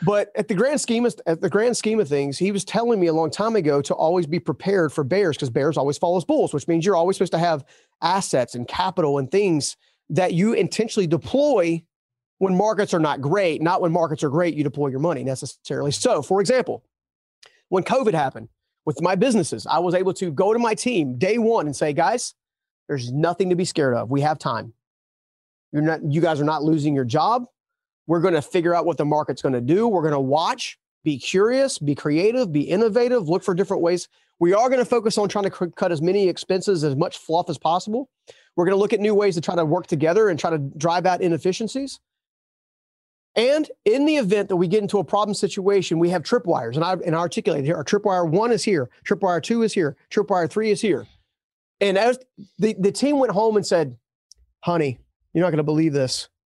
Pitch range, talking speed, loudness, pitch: 155-205 Hz, 225 wpm, -21 LUFS, 180 Hz